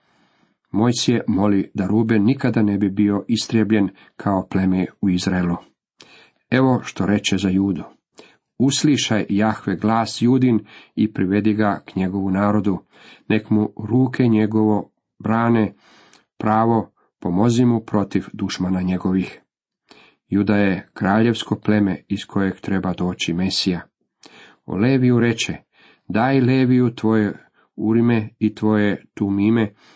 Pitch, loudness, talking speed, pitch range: 105 Hz, -19 LUFS, 120 wpm, 95-115 Hz